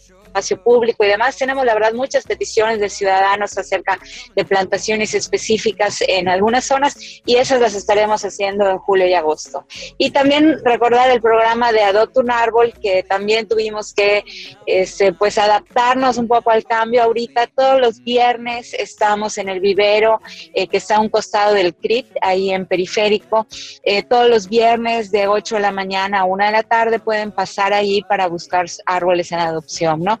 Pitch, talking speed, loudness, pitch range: 210 Hz, 175 wpm, -16 LUFS, 195-235 Hz